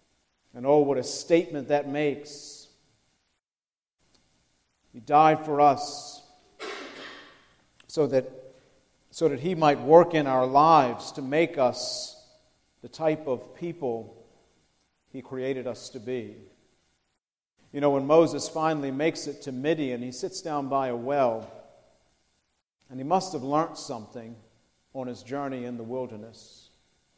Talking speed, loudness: 130 wpm, -26 LUFS